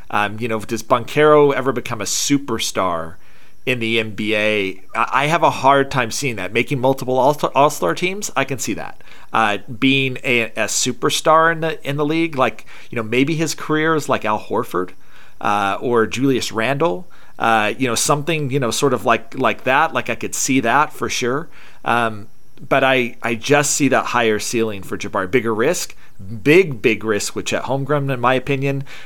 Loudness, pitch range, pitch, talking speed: -18 LUFS, 110-140 Hz, 125 Hz, 190 wpm